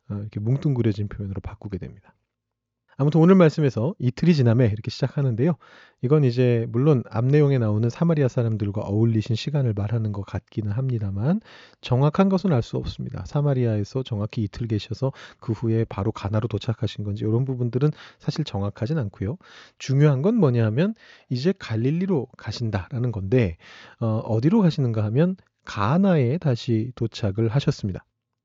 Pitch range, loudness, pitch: 110-145 Hz, -23 LUFS, 120 Hz